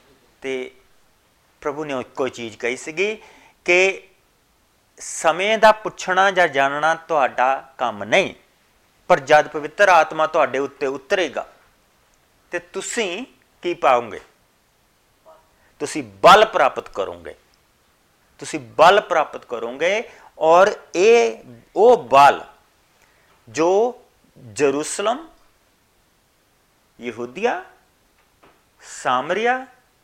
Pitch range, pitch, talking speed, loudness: 130-195 Hz, 155 Hz, 85 wpm, -18 LUFS